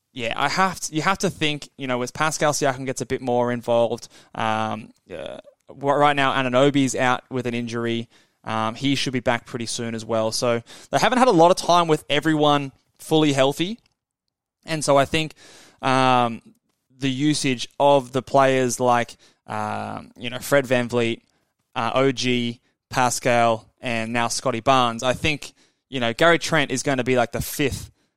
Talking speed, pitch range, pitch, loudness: 180 wpm, 120-145 Hz, 130 Hz, -21 LUFS